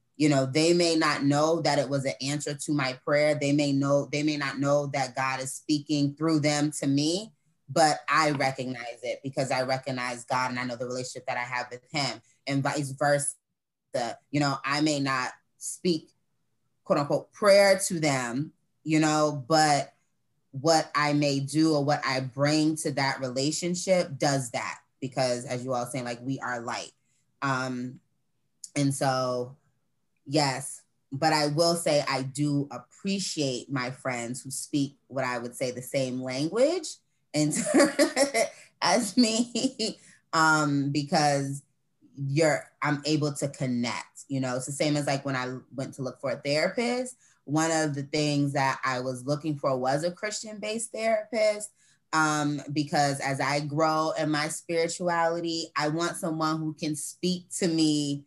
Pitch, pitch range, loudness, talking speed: 145 Hz, 135-160 Hz, -27 LUFS, 165 wpm